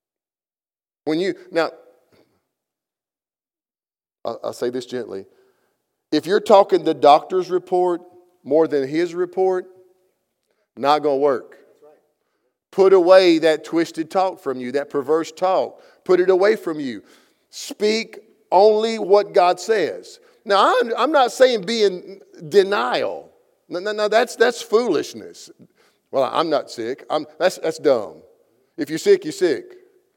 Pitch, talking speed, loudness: 205 Hz, 135 wpm, -19 LUFS